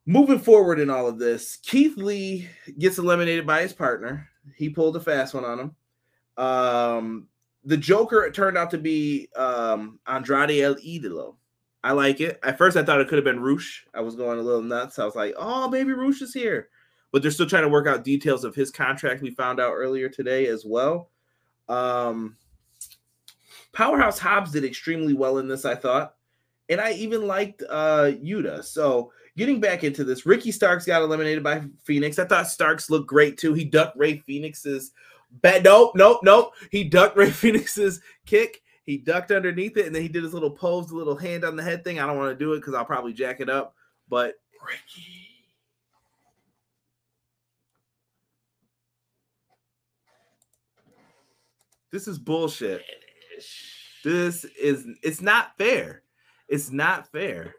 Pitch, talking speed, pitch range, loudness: 150 Hz, 170 wpm, 130-185 Hz, -22 LUFS